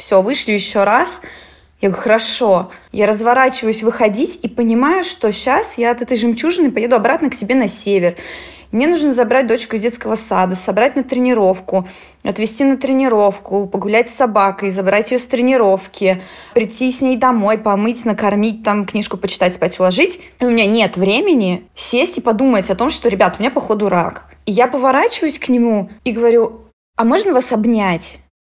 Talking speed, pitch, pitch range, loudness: 170 wpm, 225 Hz, 200-255 Hz, -15 LUFS